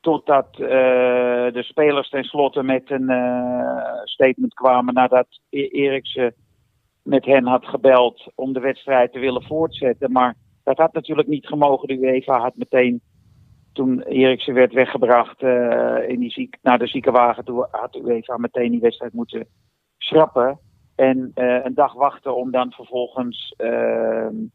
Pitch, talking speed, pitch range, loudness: 125 Hz, 150 wpm, 120-135 Hz, -19 LUFS